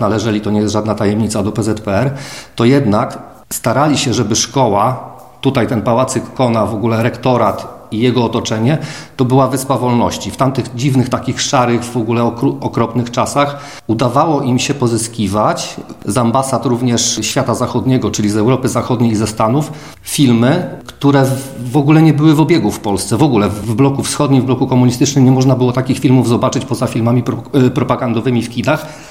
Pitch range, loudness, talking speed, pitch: 115-135 Hz, -14 LUFS, 175 wpm, 125 Hz